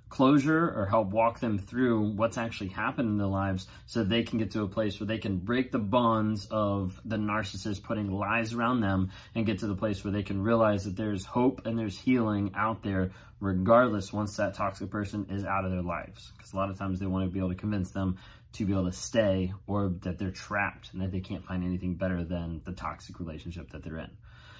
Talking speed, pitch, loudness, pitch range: 230 wpm, 100 Hz, -30 LUFS, 95-115 Hz